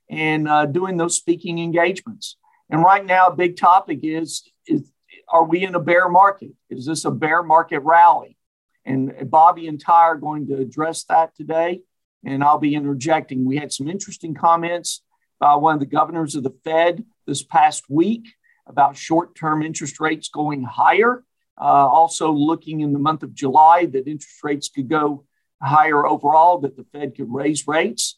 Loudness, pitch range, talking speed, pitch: -18 LUFS, 145-170 Hz, 180 wpm, 160 Hz